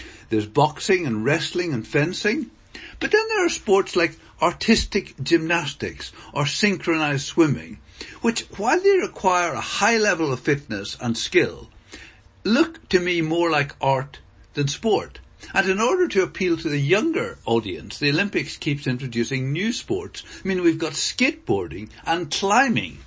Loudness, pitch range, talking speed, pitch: -22 LUFS, 145-210 Hz, 150 wpm, 170 Hz